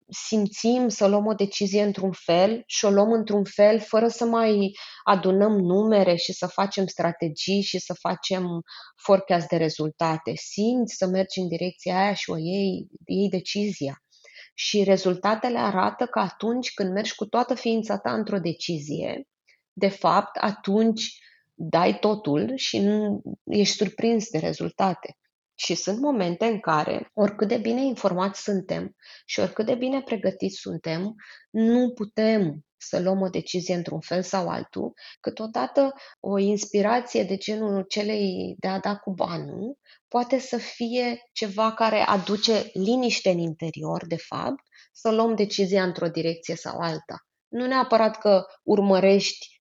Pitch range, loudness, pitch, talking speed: 185-220 Hz, -24 LUFS, 200 Hz, 145 wpm